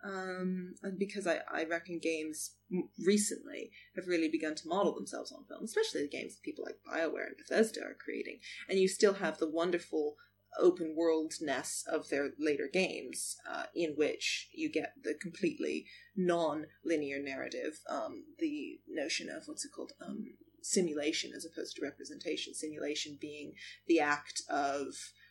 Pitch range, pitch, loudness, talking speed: 155-220 Hz, 175 Hz, -36 LUFS, 160 wpm